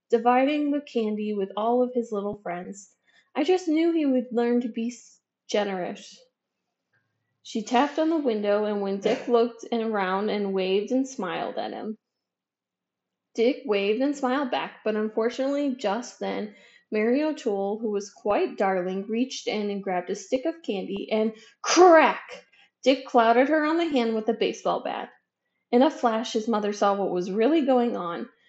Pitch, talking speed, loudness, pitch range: 235 Hz, 170 wpm, -25 LUFS, 210-260 Hz